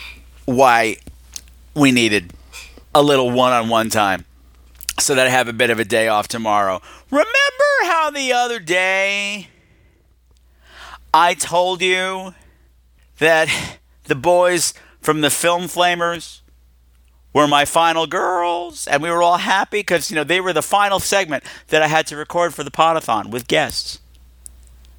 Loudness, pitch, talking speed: -17 LUFS, 145 Hz, 150 wpm